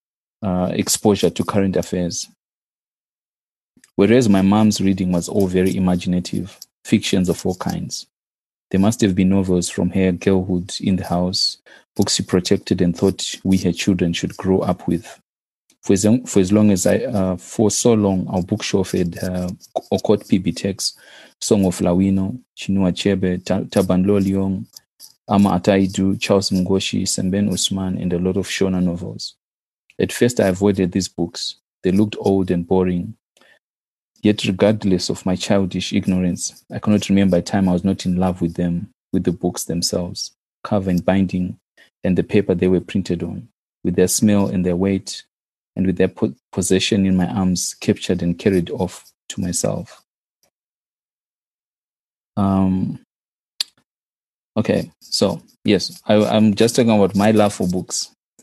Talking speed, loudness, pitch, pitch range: 155 wpm, -19 LUFS, 95 Hz, 90-100 Hz